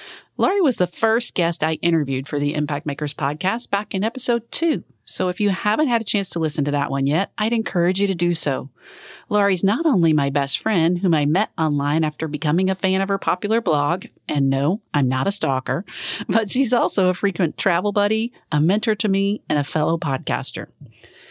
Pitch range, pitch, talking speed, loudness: 150-210 Hz, 180 Hz, 210 wpm, -21 LUFS